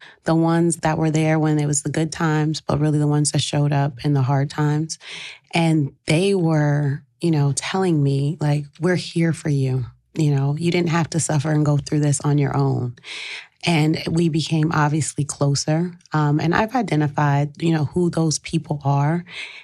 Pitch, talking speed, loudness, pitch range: 150 Hz, 195 wpm, -20 LUFS, 145-165 Hz